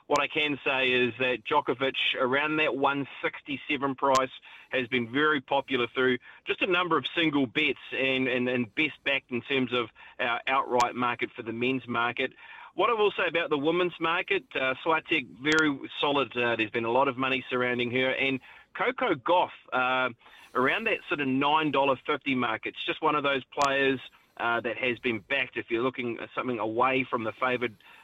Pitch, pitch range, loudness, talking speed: 130 Hz, 125-150 Hz, -27 LUFS, 190 wpm